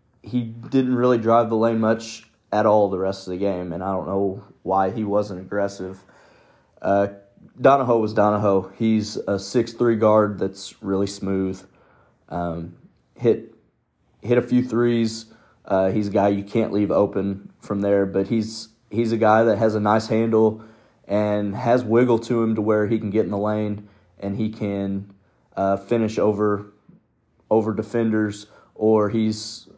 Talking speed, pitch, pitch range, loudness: 165 wpm, 105 Hz, 100-115 Hz, -21 LUFS